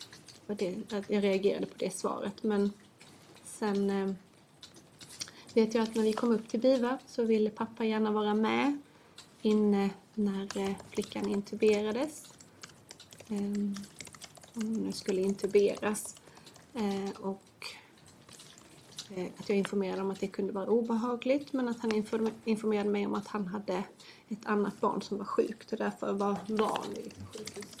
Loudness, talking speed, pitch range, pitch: -32 LUFS, 135 wpm, 200-220 Hz, 210 Hz